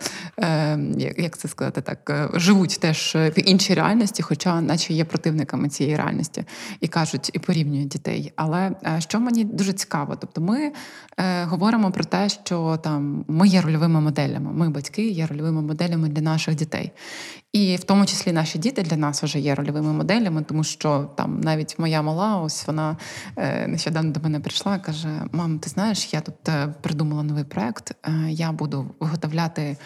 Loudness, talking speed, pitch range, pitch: -23 LUFS, 160 wpm, 155-190 Hz, 160 Hz